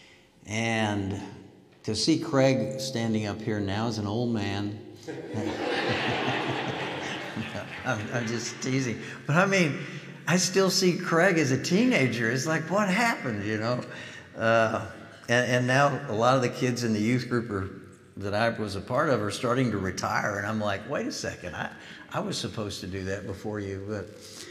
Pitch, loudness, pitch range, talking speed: 115 Hz, -27 LUFS, 105-135 Hz, 175 wpm